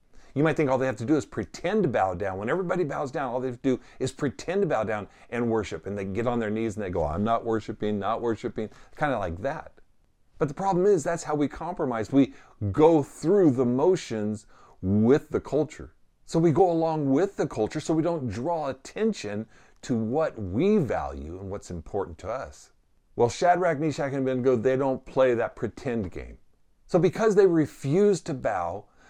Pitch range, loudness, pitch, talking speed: 110-160 Hz, -26 LUFS, 130 Hz, 210 wpm